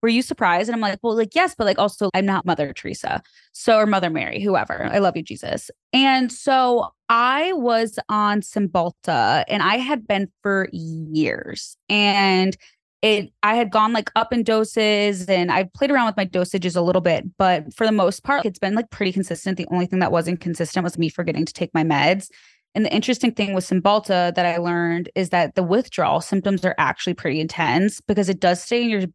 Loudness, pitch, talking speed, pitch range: -20 LUFS, 195 Hz, 210 wpm, 175-220 Hz